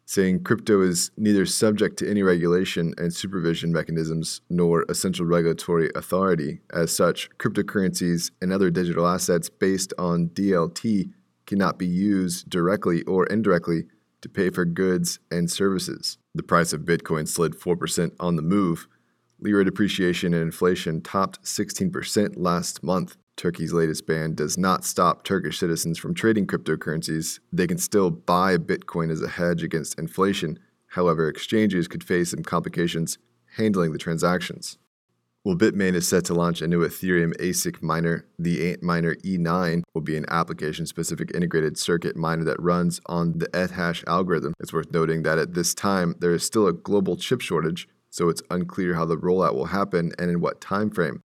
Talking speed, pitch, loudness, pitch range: 165 wpm, 85 Hz, -24 LUFS, 80-90 Hz